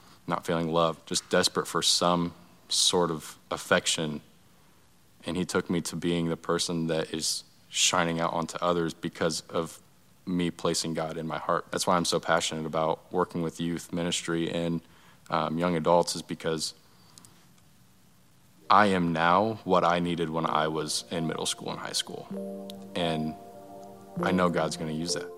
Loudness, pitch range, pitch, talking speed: -28 LUFS, 80-90 Hz, 85 Hz, 170 wpm